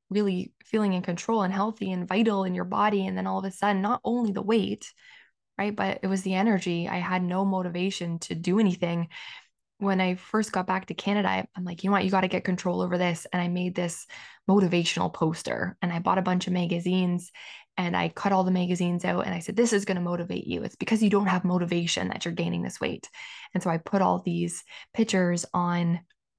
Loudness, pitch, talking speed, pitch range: -27 LUFS, 185 Hz, 230 wpm, 175-200 Hz